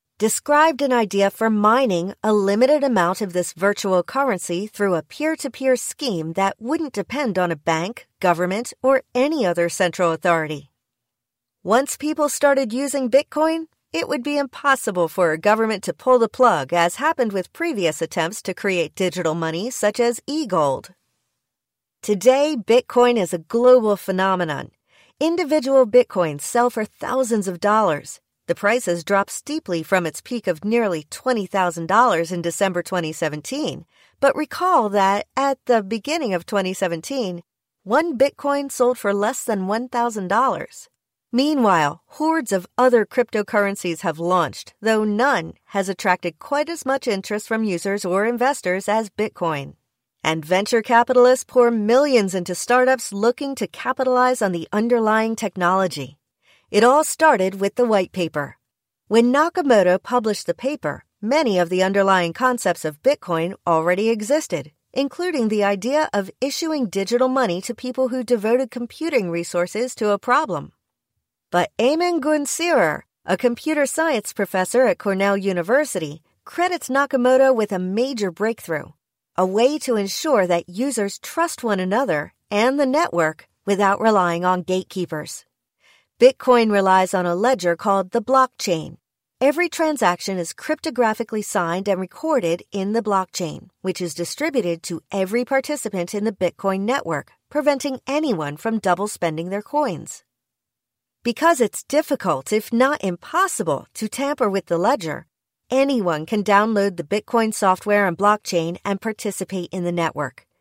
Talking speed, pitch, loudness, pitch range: 145 wpm, 210 Hz, -20 LUFS, 180-255 Hz